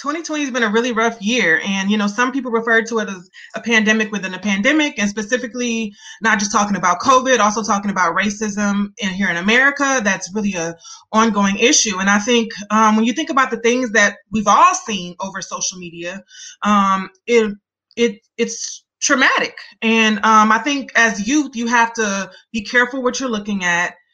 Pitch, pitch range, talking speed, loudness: 220 Hz, 200-245 Hz, 195 wpm, -16 LUFS